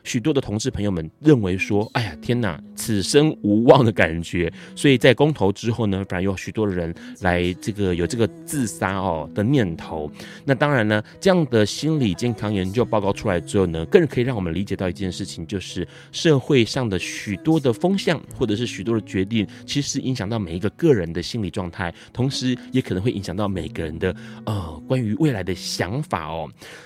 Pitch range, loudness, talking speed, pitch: 95-130 Hz, -22 LUFS, 310 characters per minute, 105 Hz